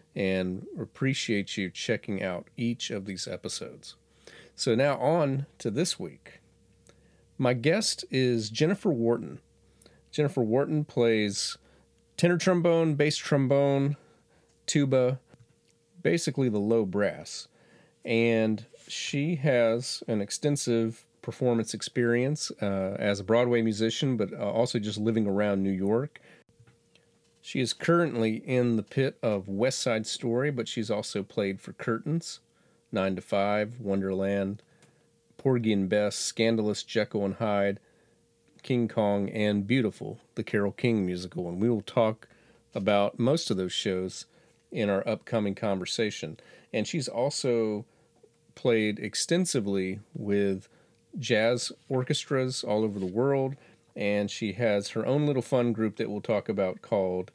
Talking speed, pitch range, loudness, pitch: 130 wpm, 100-135 Hz, -28 LUFS, 115 Hz